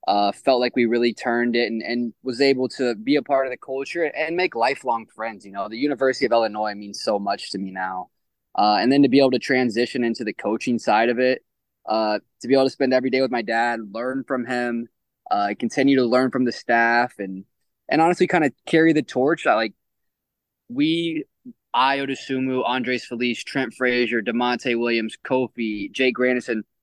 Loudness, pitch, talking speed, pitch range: -22 LUFS, 125 Hz, 200 wpm, 115-135 Hz